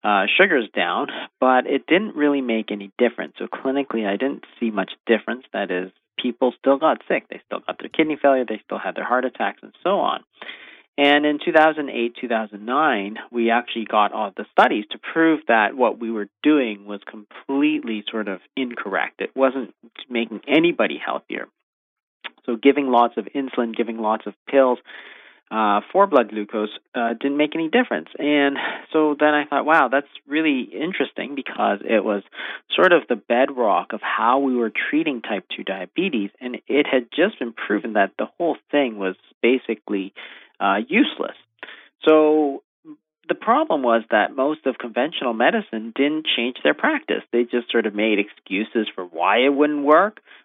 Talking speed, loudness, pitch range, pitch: 175 wpm, -21 LUFS, 110-145 Hz, 125 Hz